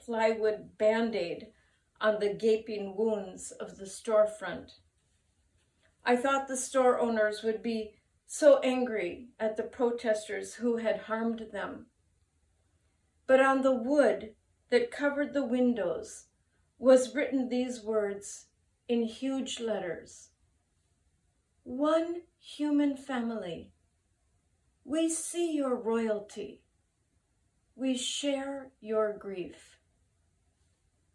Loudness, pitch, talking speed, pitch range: -30 LUFS, 225 Hz, 100 wpm, 195-260 Hz